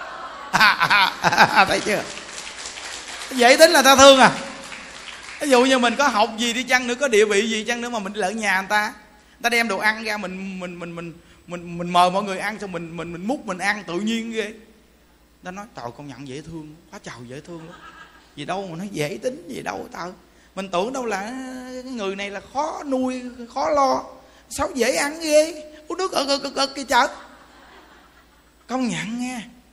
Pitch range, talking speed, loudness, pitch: 180-260 Hz, 210 wpm, -19 LUFS, 220 Hz